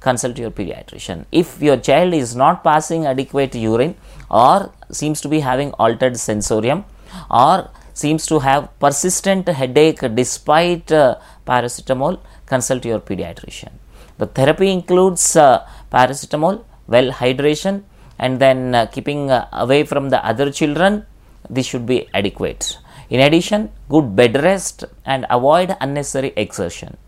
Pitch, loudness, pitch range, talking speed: 135 Hz, -16 LUFS, 125-160 Hz, 135 wpm